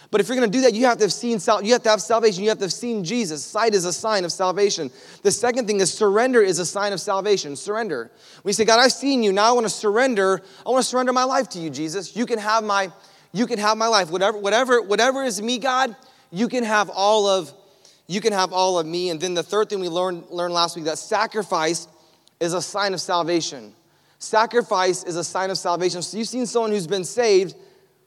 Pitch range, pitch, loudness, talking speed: 185-230 Hz, 205 Hz, -21 LUFS, 250 wpm